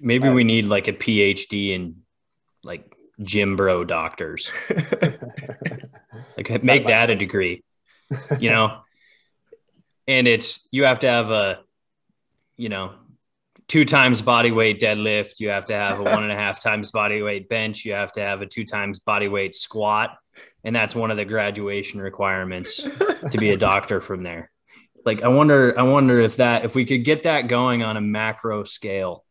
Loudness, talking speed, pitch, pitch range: -20 LUFS, 175 wpm, 110 Hz, 100-125 Hz